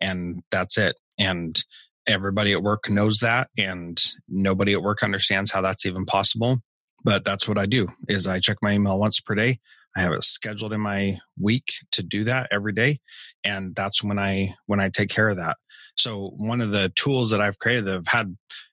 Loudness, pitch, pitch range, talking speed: -23 LUFS, 105 Hz, 95-110 Hz, 205 wpm